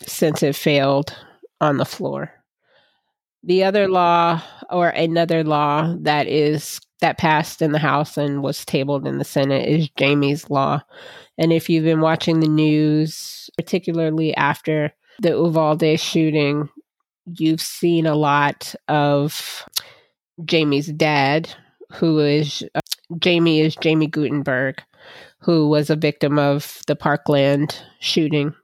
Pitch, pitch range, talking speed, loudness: 155 Hz, 145-165 Hz, 130 wpm, -19 LUFS